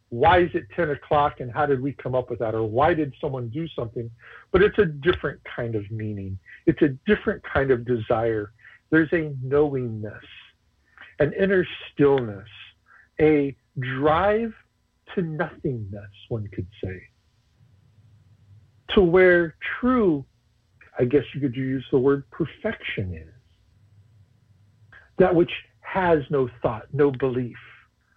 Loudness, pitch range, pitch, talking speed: -23 LUFS, 110-155 Hz, 130 Hz, 135 wpm